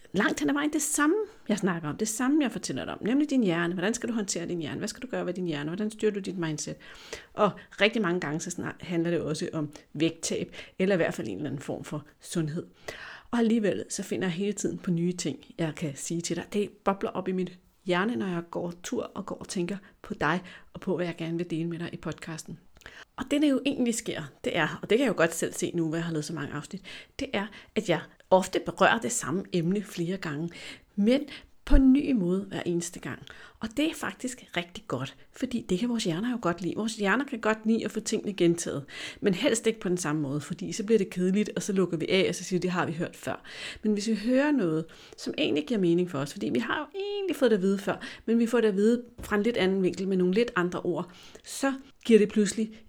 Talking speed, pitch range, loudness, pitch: 260 wpm, 170-225 Hz, -29 LUFS, 190 Hz